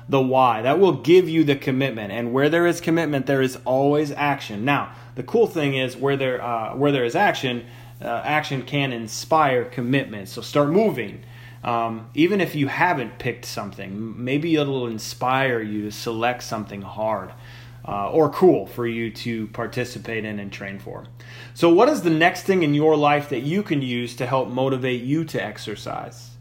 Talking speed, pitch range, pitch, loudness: 185 wpm, 115-145 Hz, 125 Hz, -22 LUFS